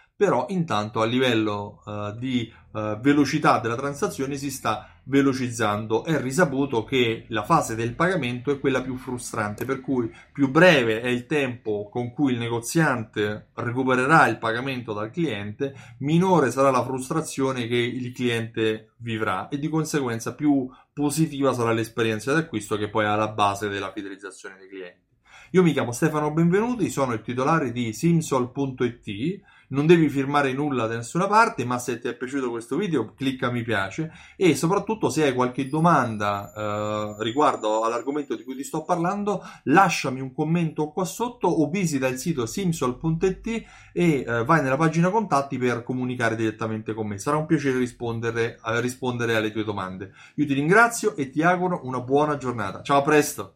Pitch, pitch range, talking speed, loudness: 130 Hz, 115-155 Hz, 165 wpm, -24 LUFS